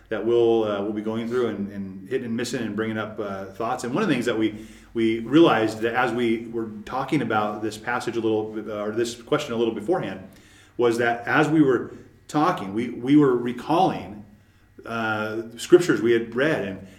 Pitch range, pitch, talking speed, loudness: 110-120 Hz, 115 Hz, 205 wpm, -23 LUFS